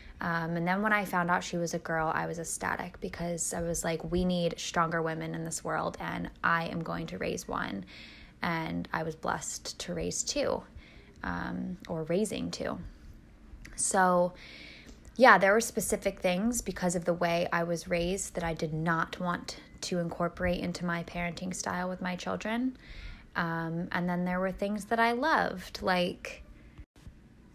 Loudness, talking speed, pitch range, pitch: -31 LUFS, 175 wpm, 165-185 Hz, 175 Hz